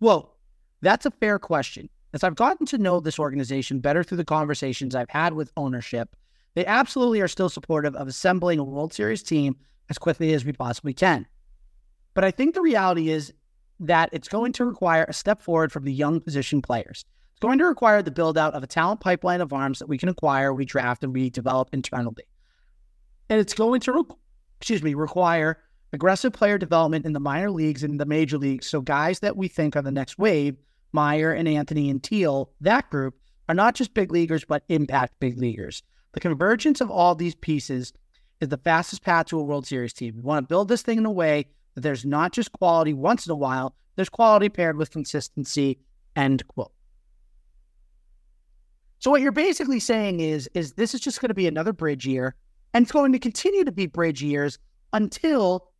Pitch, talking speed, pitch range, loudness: 160 Hz, 200 wpm, 140-195 Hz, -23 LUFS